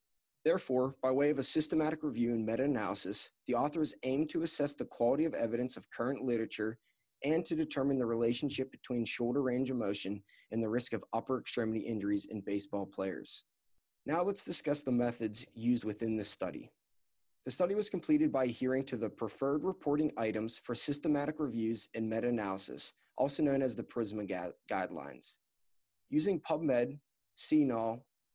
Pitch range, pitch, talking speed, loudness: 110-145 Hz, 120 Hz, 165 wpm, -34 LUFS